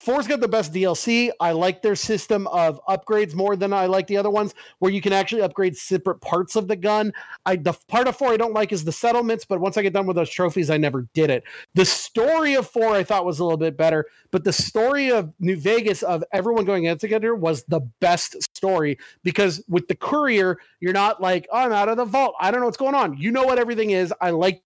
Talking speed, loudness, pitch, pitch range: 250 wpm, -21 LUFS, 195 Hz, 180-225 Hz